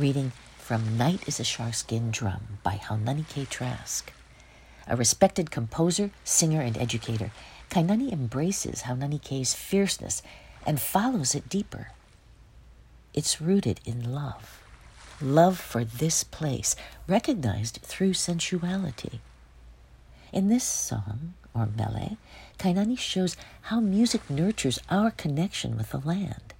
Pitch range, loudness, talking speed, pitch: 115-185 Hz, -27 LUFS, 115 wpm, 140 Hz